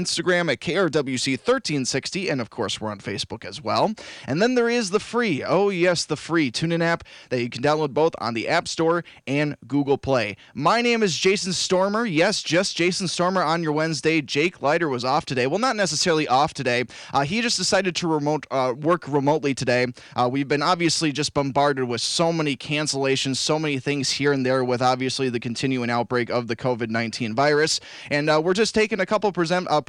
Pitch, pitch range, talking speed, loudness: 150 Hz, 130-175 Hz, 205 wpm, -22 LUFS